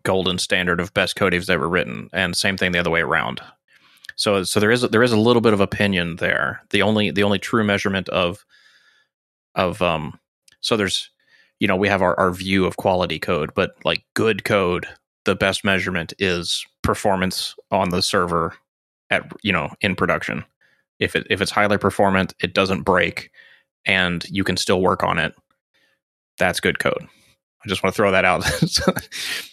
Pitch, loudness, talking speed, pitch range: 95 Hz, -20 LUFS, 185 wpm, 90-100 Hz